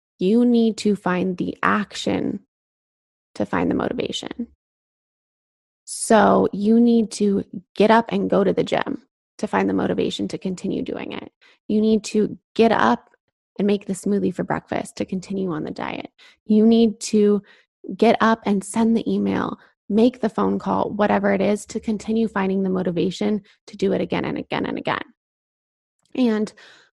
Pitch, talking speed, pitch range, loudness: 205 Hz, 165 wpm, 190-225 Hz, -21 LUFS